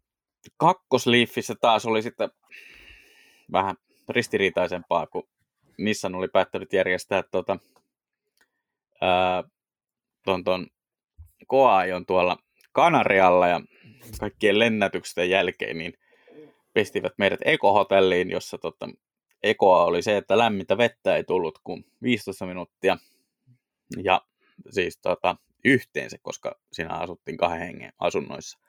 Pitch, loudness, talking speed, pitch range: 95 Hz, -24 LUFS, 95 wpm, 90-115 Hz